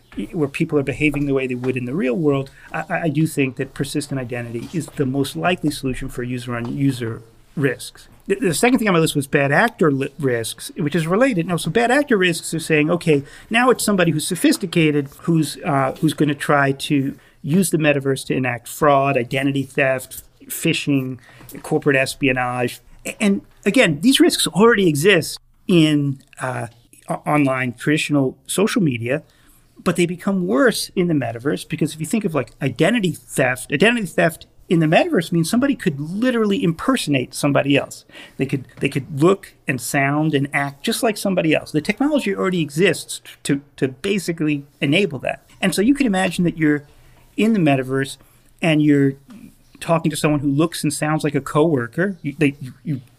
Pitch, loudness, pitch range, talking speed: 150 Hz, -19 LUFS, 135-175 Hz, 185 wpm